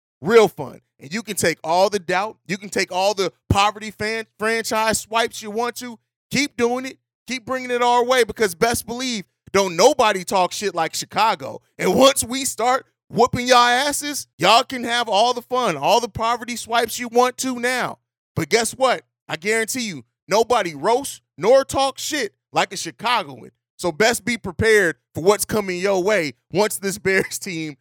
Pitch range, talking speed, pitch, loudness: 180-245 Hz, 185 wpm, 220 Hz, -20 LUFS